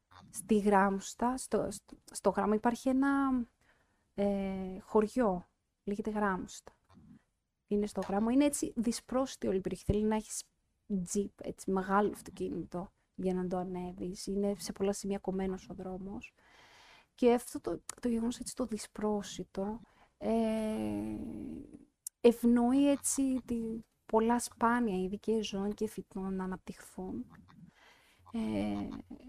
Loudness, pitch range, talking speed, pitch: -34 LUFS, 190-240 Hz, 120 wpm, 210 Hz